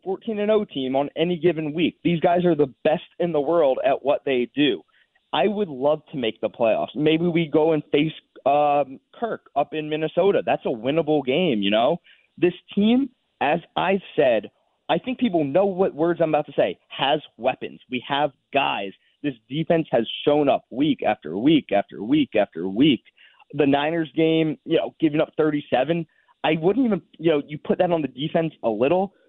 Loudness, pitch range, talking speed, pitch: -22 LUFS, 150-185 Hz, 195 wpm, 160 Hz